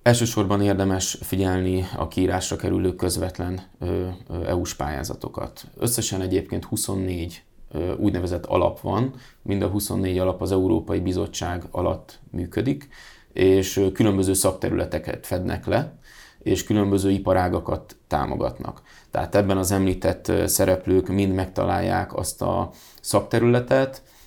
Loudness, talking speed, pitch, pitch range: -24 LUFS, 105 wpm, 95 Hz, 90-100 Hz